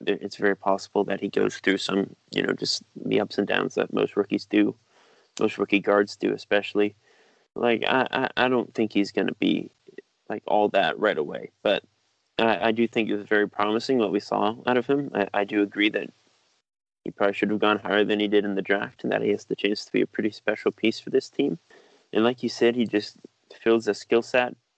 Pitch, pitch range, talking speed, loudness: 105 Hz, 100-115 Hz, 230 wpm, -25 LUFS